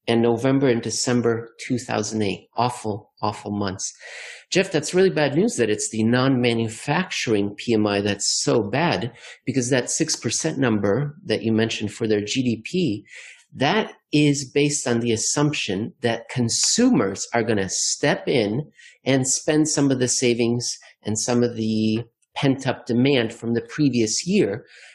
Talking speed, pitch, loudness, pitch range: 145 wpm, 120 Hz, -22 LUFS, 110-140 Hz